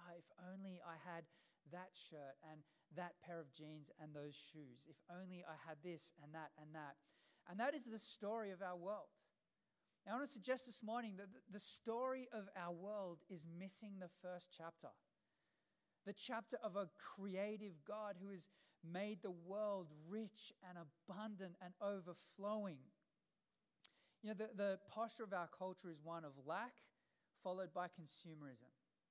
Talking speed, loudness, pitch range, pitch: 165 wpm, -51 LUFS, 165-210 Hz, 185 Hz